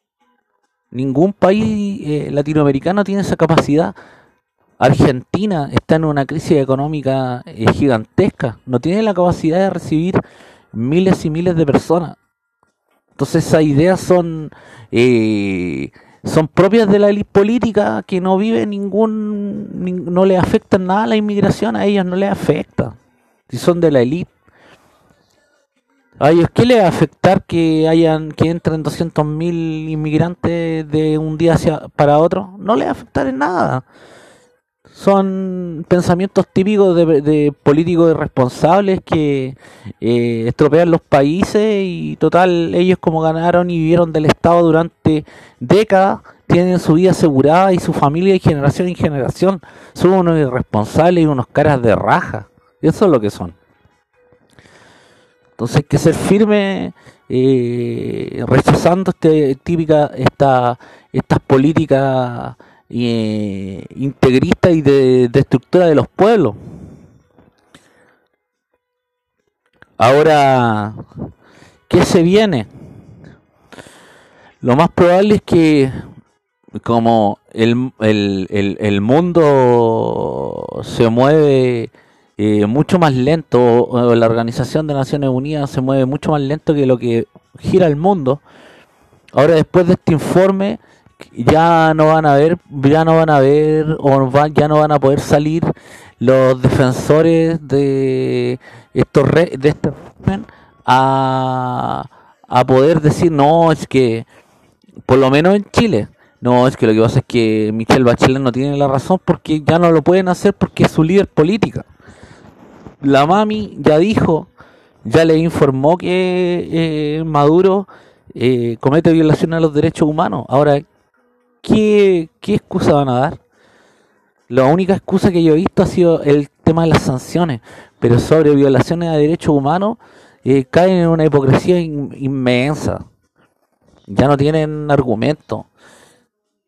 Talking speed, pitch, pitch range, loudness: 135 wpm, 155 Hz, 135-180 Hz, -14 LUFS